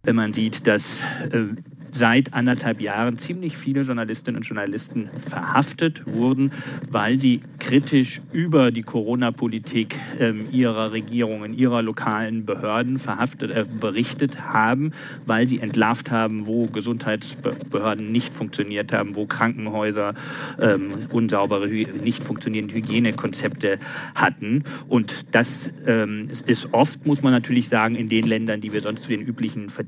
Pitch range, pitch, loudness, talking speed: 110-135 Hz, 115 Hz, -22 LUFS, 135 wpm